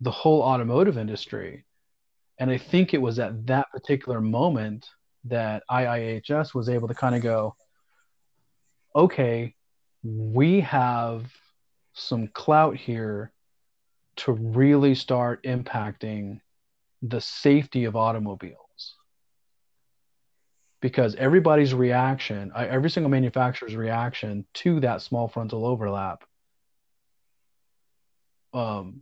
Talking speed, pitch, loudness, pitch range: 100 wpm, 125 Hz, -24 LUFS, 110-135 Hz